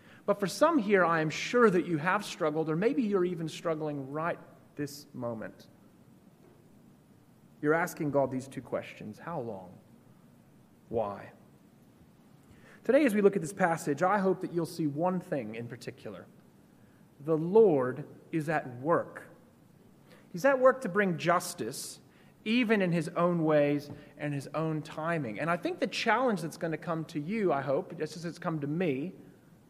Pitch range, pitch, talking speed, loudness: 150-190 Hz, 165 Hz, 170 wpm, -30 LUFS